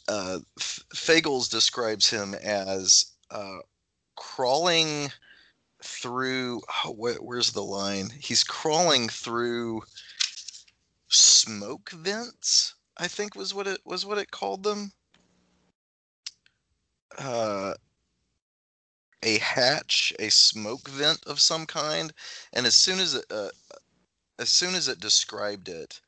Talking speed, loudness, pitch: 115 wpm, -24 LUFS, 120 Hz